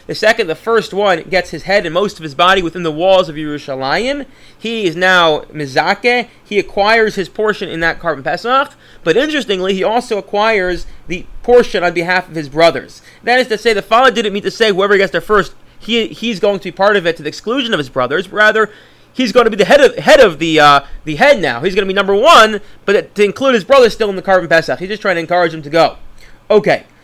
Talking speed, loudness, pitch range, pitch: 245 wpm, -13 LUFS, 170-220 Hz, 195 Hz